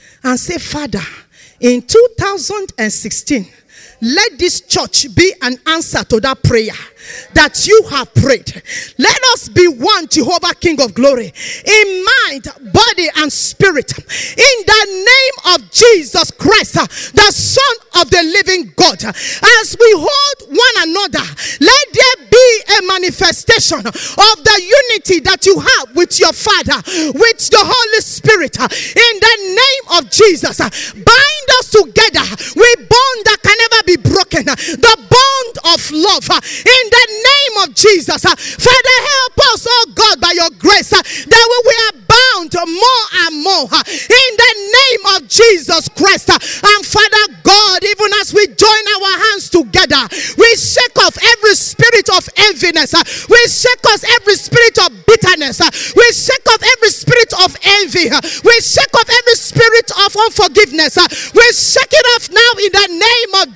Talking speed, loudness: 150 wpm, -8 LUFS